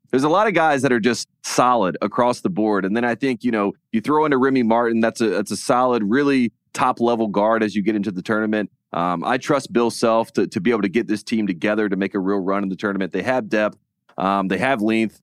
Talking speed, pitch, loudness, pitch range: 265 wpm, 110 Hz, -20 LUFS, 100-120 Hz